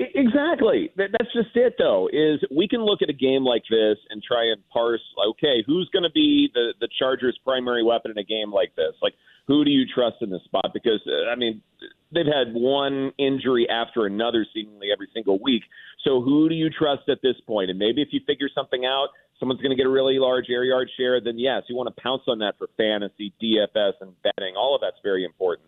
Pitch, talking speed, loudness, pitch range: 130 Hz, 225 wpm, -23 LUFS, 115-170 Hz